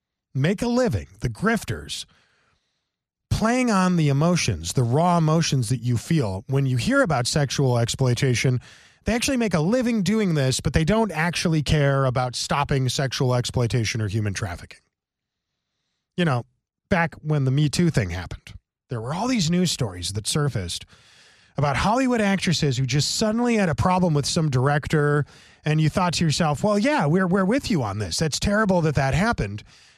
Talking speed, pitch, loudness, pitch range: 175 wpm, 145 Hz, -22 LUFS, 125-180 Hz